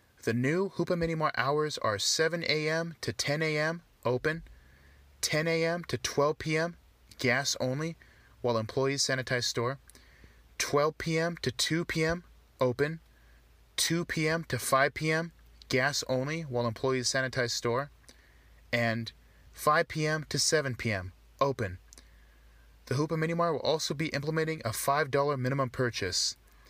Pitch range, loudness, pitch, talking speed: 120-160 Hz, -30 LUFS, 140 Hz, 130 wpm